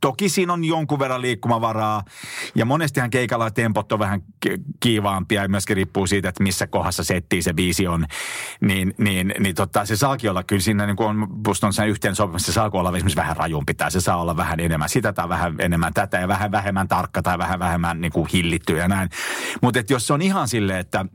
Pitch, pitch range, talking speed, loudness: 100 Hz, 90-115 Hz, 205 wpm, -21 LUFS